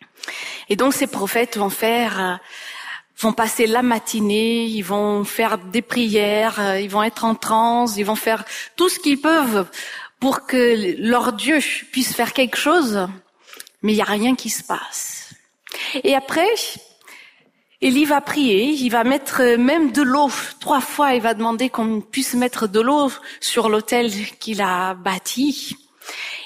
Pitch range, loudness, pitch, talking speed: 215-270 Hz, -19 LUFS, 235 Hz, 155 wpm